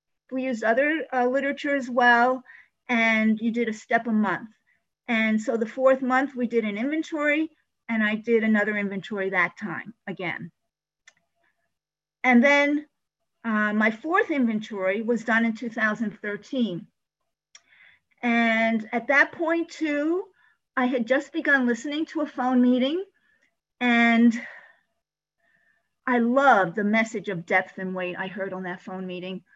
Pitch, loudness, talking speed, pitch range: 235 Hz, -24 LUFS, 140 wpm, 215-275 Hz